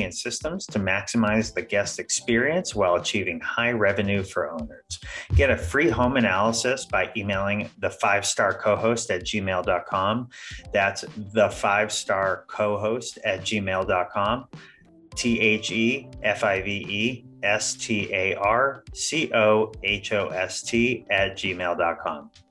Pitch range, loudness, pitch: 100-120 Hz, -24 LUFS, 105 Hz